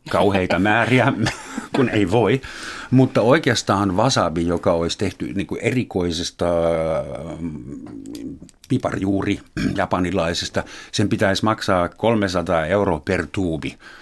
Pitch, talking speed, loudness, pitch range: 100 Hz, 95 wpm, -20 LUFS, 85-110 Hz